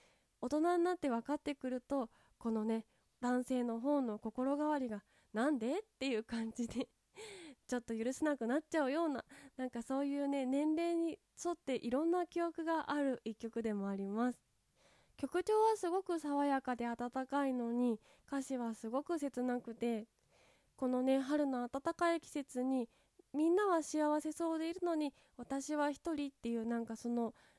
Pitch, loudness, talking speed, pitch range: 275 Hz, -38 LUFS, 315 characters per minute, 240-305 Hz